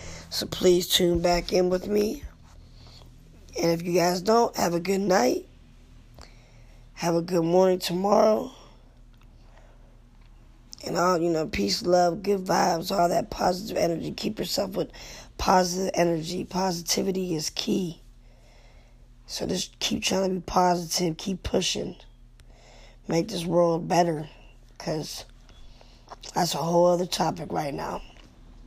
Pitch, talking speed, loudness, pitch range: 175 Hz, 130 wpm, -25 LUFS, 170-185 Hz